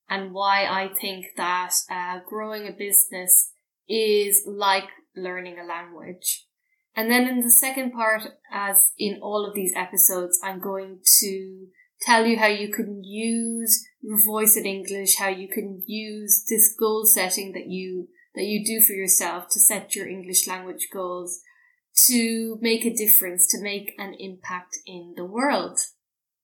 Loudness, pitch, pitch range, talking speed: -20 LUFS, 200 Hz, 185-220 Hz, 160 wpm